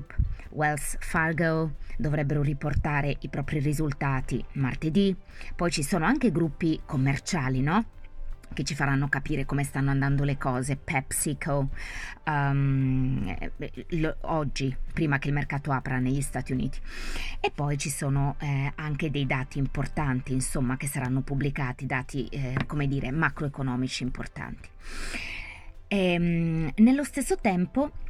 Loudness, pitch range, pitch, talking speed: -28 LUFS, 130-155 Hz, 140 Hz, 130 wpm